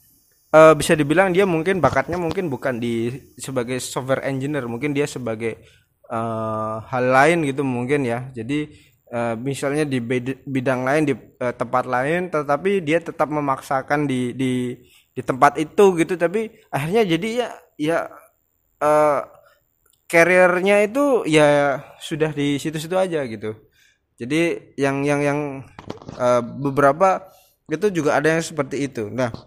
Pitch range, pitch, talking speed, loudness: 125-160 Hz, 145 Hz, 140 wpm, -20 LUFS